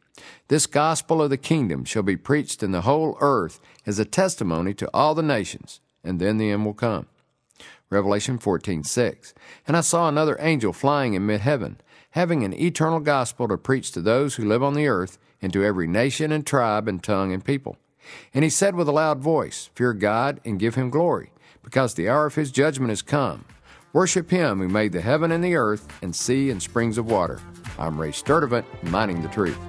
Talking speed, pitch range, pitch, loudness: 205 wpm, 100-150 Hz, 125 Hz, -23 LUFS